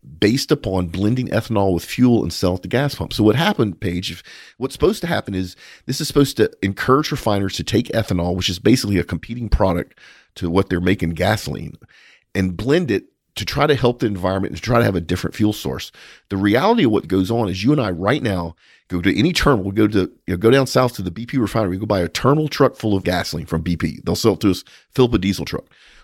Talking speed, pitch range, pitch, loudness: 250 wpm, 90-120 Hz, 100 Hz, -19 LUFS